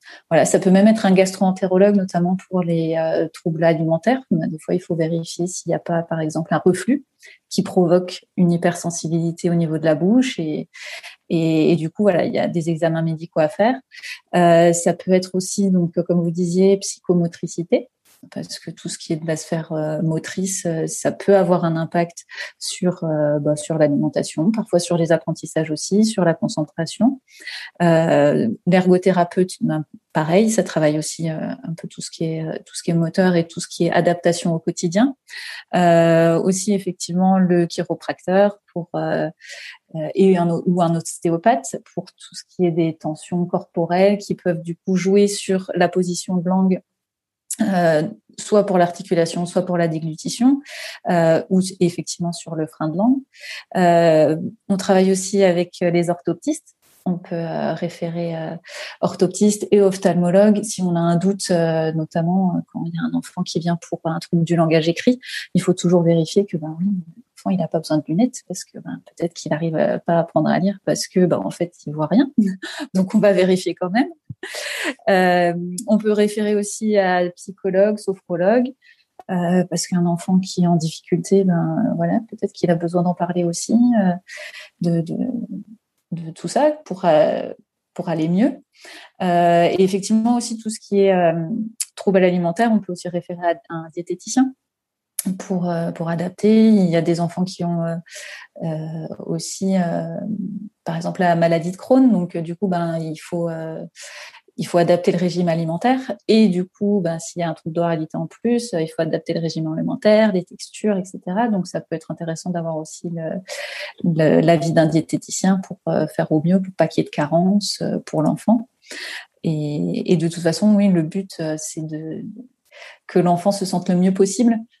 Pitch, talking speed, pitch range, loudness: 180 Hz, 185 wpm, 165-200 Hz, -19 LUFS